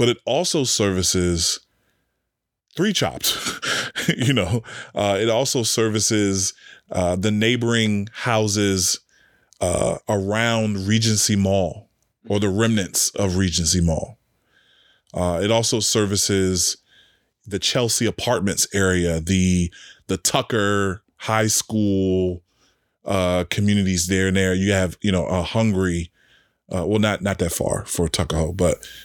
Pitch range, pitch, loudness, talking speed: 95-110 Hz, 100 Hz, -20 LUFS, 120 wpm